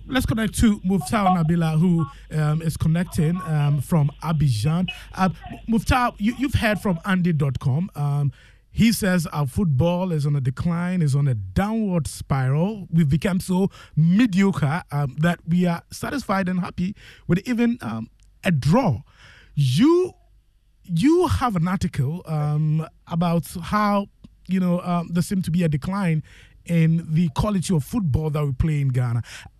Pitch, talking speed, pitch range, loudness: 170 Hz, 160 wpm, 150-190 Hz, -22 LUFS